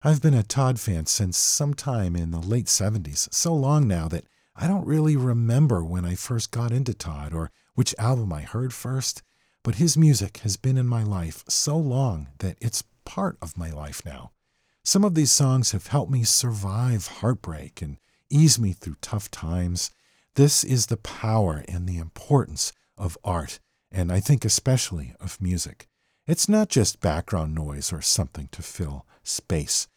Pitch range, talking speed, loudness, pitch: 85-130 Hz, 180 wpm, -24 LUFS, 110 Hz